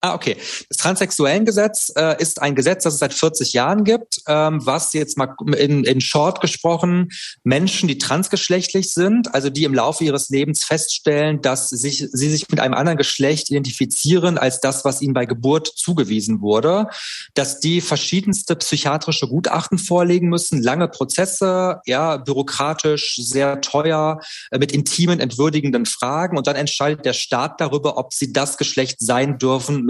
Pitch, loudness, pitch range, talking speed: 150 Hz, -18 LUFS, 140-170 Hz, 155 wpm